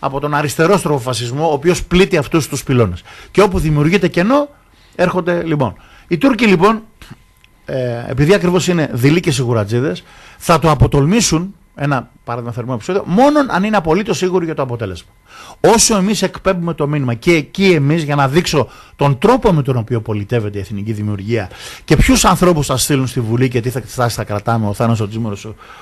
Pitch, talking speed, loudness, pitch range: 145 Hz, 180 wpm, -15 LUFS, 120-180 Hz